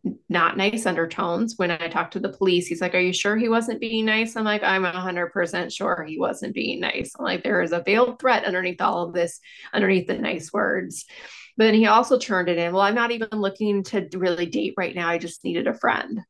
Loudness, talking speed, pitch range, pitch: -23 LUFS, 235 wpm, 180-220 Hz, 195 Hz